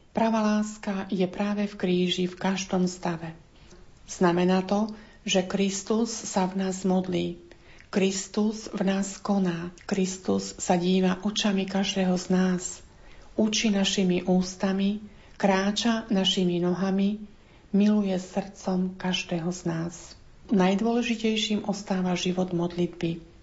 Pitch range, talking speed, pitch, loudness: 180-205 Hz, 110 wpm, 190 Hz, -26 LUFS